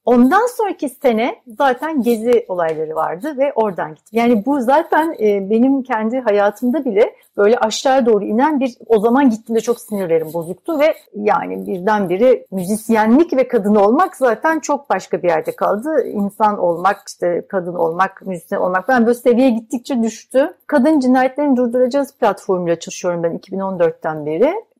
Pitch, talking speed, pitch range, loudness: 230 Hz, 150 wpm, 195-270 Hz, -16 LUFS